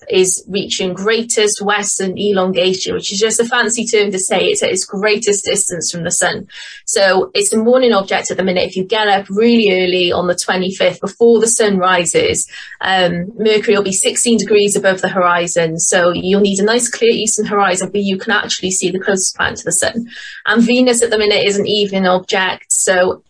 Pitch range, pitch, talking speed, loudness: 185-225 Hz, 205 Hz, 210 wpm, -13 LUFS